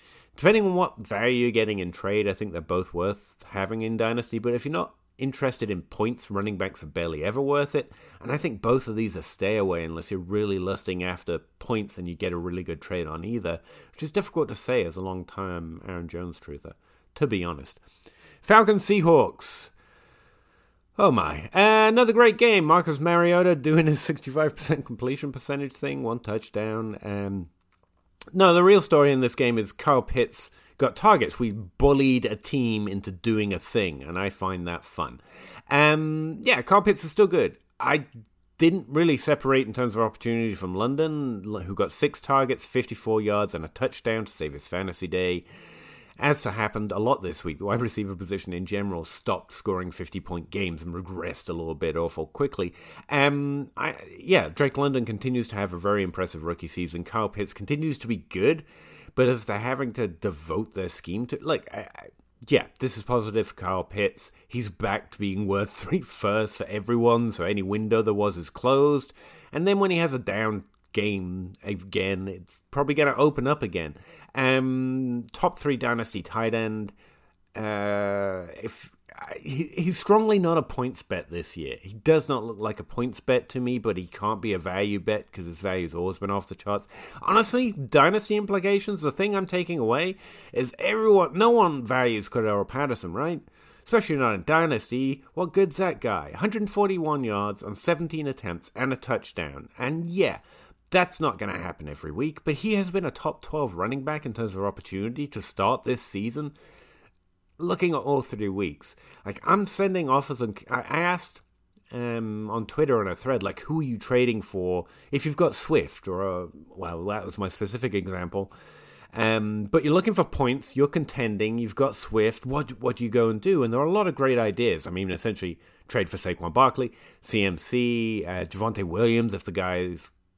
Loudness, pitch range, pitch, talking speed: -26 LUFS, 95-145 Hz, 115 Hz, 190 wpm